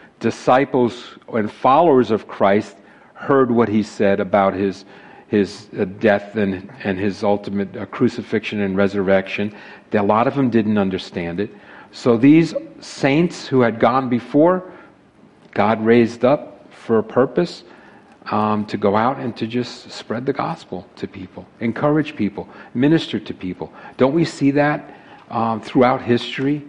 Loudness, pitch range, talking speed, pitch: -19 LUFS, 100-135 Hz, 145 wpm, 115 Hz